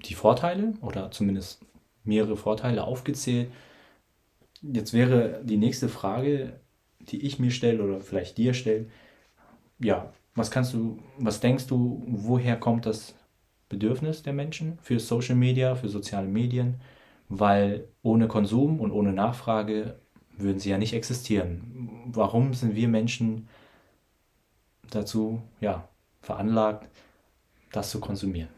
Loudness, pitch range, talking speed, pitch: -27 LUFS, 105-125 Hz, 125 wpm, 115 Hz